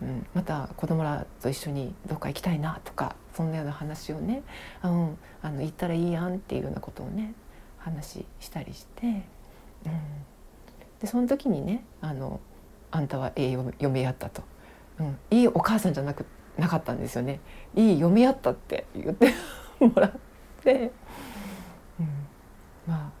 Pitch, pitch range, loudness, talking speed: 160 Hz, 140-190 Hz, -28 LUFS, 305 characters per minute